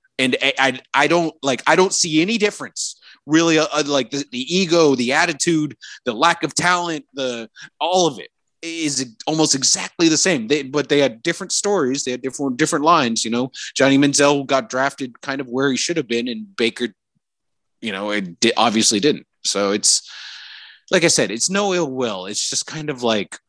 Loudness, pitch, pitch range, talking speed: -18 LUFS, 140 Hz, 125-160 Hz, 195 wpm